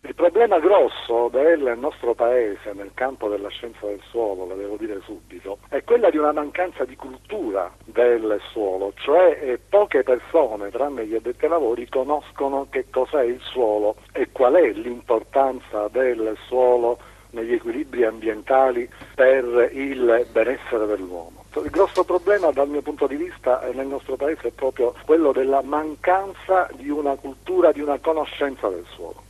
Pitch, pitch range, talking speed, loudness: 130 Hz, 115-155 Hz, 155 wpm, -21 LUFS